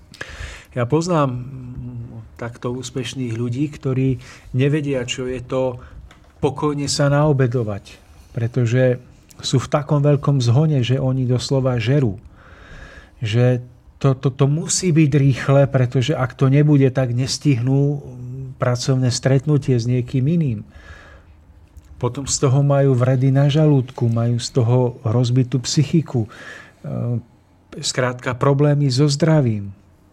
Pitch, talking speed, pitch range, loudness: 130 Hz, 115 wpm, 120-140 Hz, -19 LUFS